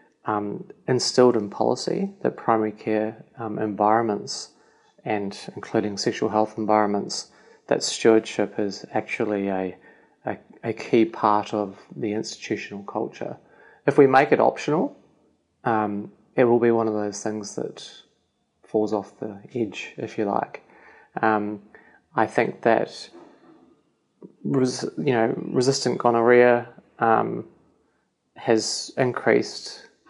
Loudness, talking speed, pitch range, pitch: -23 LUFS, 120 wpm, 105-120 Hz, 110 Hz